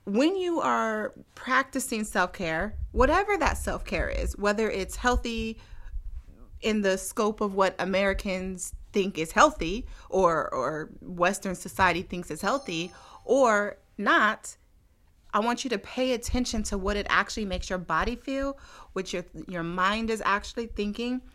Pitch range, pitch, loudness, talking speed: 180-235 Hz, 200 Hz, -27 LUFS, 145 wpm